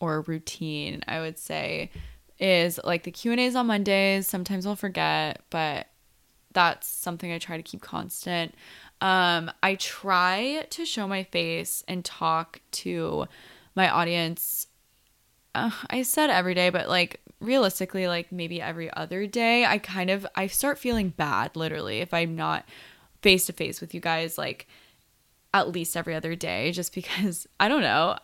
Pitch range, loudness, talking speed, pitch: 165-195 Hz, -26 LUFS, 165 wpm, 180 Hz